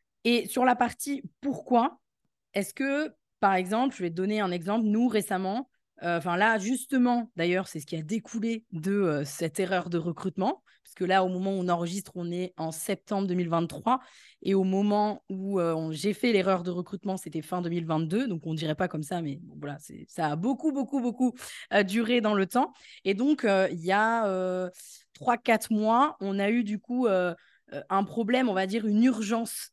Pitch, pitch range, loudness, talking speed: 200 Hz, 180-230 Hz, -28 LUFS, 205 wpm